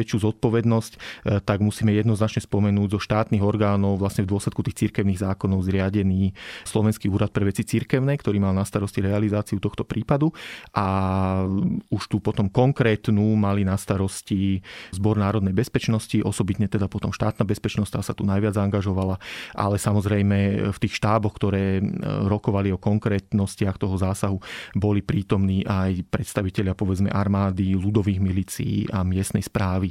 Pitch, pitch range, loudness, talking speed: 105 Hz, 100-110 Hz, -23 LUFS, 140 wpm